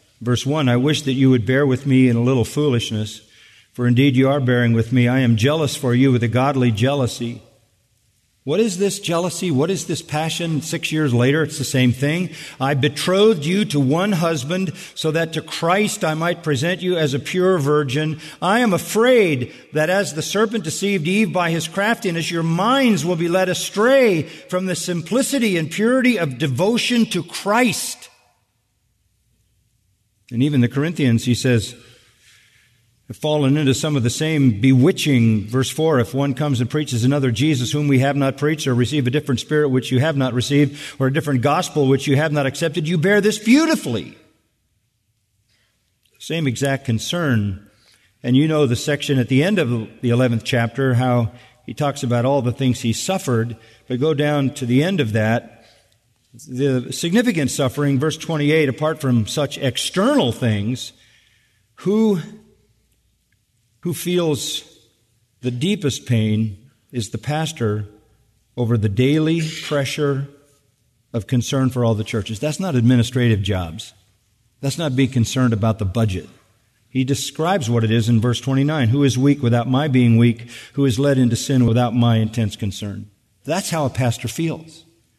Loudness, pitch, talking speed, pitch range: -19 LUFS, 130 Hz, 170 wpm, 115-155 Hz